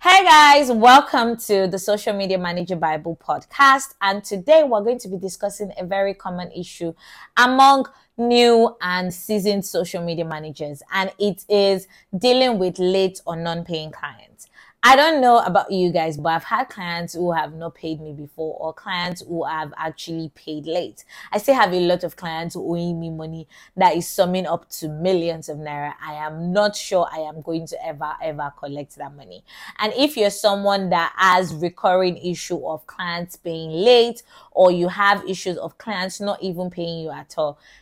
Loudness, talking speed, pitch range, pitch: -19 LUFS, 185 wpm, 165-205 Hz, 180 Hz